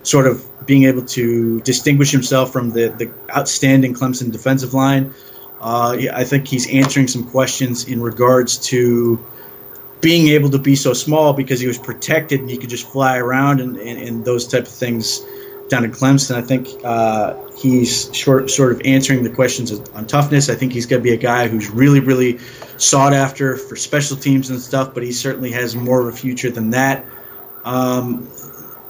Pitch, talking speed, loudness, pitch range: 130 Hz, 190 wpm, -16 LUFS, 120-135 Hz